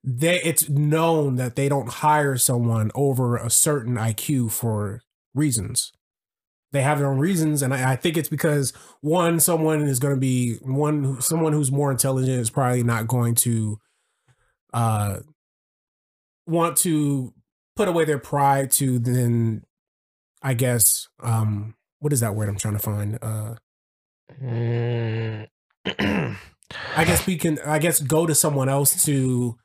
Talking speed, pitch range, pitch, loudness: 150 wpm, 115-150 Hz, 130 Hz, -22 LUFS